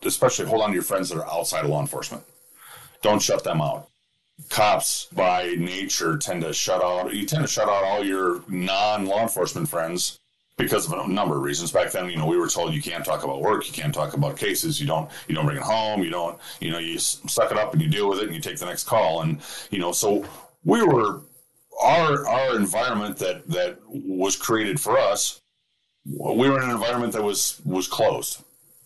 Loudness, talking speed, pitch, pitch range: -23 LUFS, 220 wpm, 100 Hz, 90-120 Hz